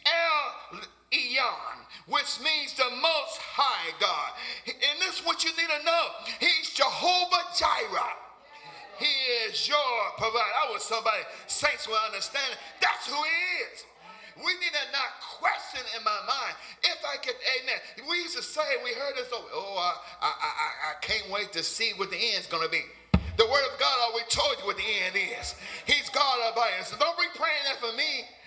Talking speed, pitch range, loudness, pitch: 190 wpm, 250-350 Hz, -27 LUFS, 305 Hz